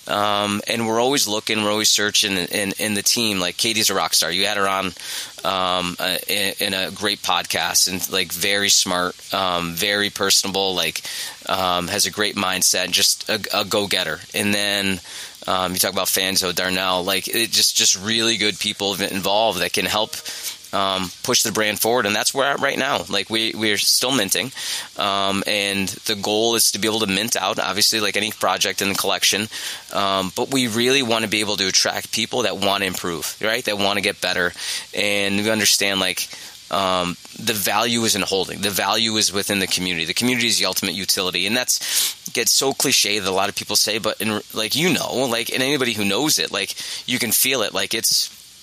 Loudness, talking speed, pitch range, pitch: -19 LUFS, 210 wpm, 95-105 Hz, 100 Hz